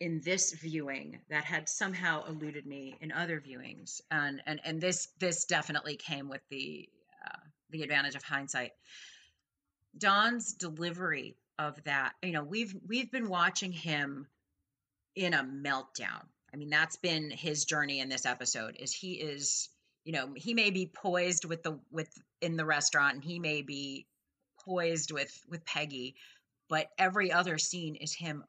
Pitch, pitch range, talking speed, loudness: 155 Hz, 140-175 Hz, 160 wpm, -33 LUFS